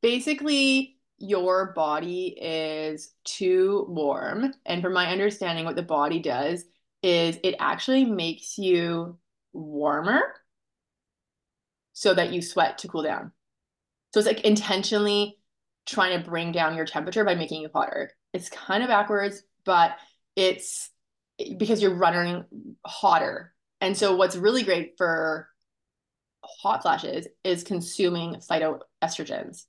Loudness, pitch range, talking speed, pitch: -25 LUFS, 165-205 Hz, 125 wpm, 185 Hz